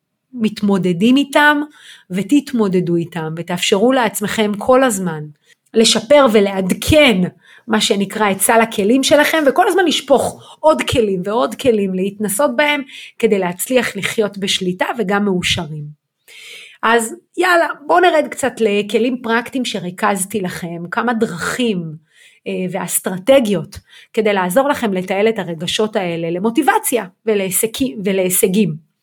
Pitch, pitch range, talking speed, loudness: 215 Hz, 190-255 Hz, 110 wpm, -15 LUFS